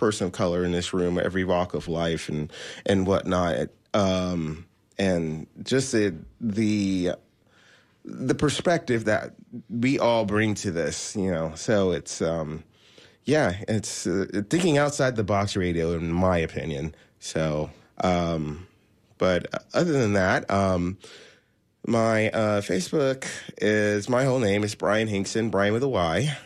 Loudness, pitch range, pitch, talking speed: -25 LUFS, 85-110 Hz, 100 Hz, 140 wpm